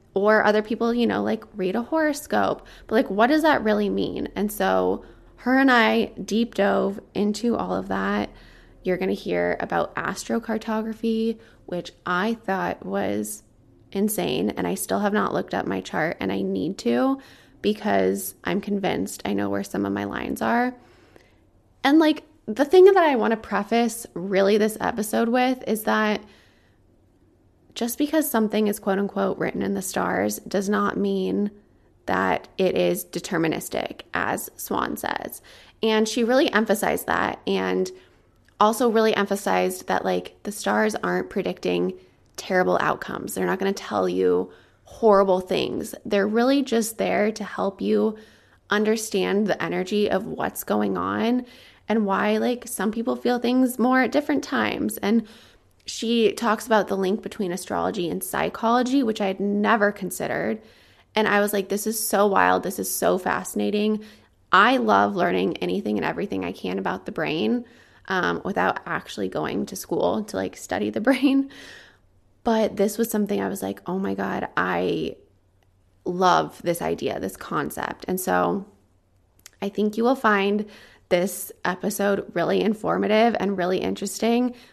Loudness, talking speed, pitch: -23 LUFS, 160 wpm, 205 Hz